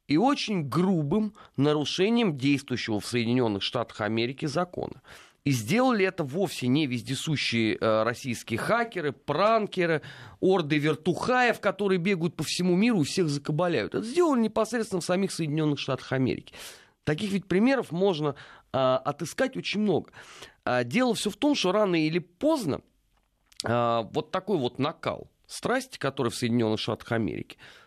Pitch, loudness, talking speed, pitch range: 160 Hz, -27 LUFS, 135 wpm, 130-200 Hz